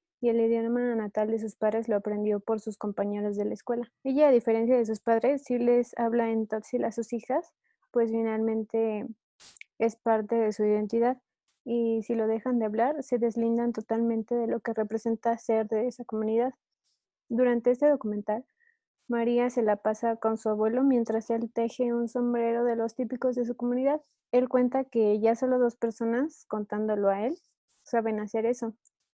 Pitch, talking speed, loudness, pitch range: 230 Hz, 180 wpm, -28 LUFS, 220-245 Hz